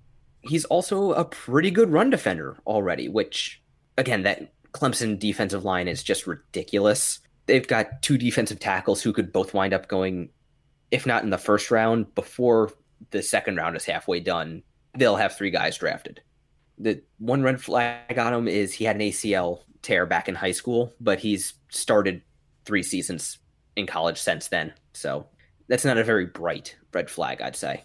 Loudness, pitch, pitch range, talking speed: -25 LUFS, 110 Hz, 100-125 Hz, 175 wpm